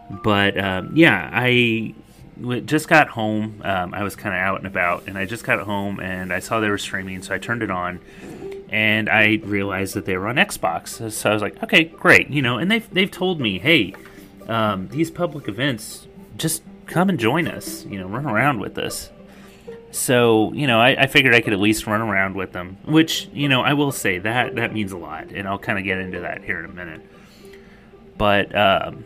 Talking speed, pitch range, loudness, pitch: 220 wpm, 100-145 Hz, -19 LUFS, 110 Hz